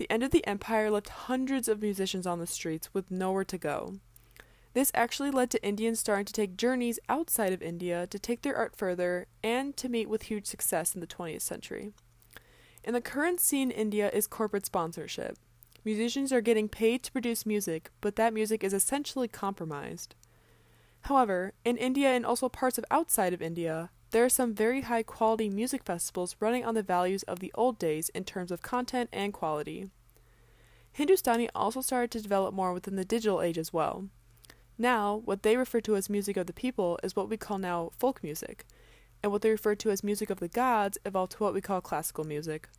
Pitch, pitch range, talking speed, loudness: 205 Hz, 175-235 Hz, 200 wpm, -31 LUFS